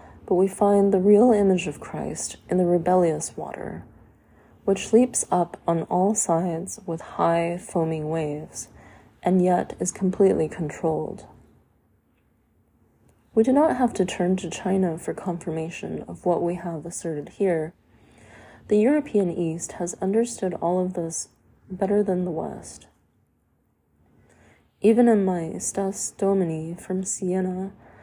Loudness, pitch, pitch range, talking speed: -24 LUFS, 180 Hz, 165-195 Hz, 135 wpm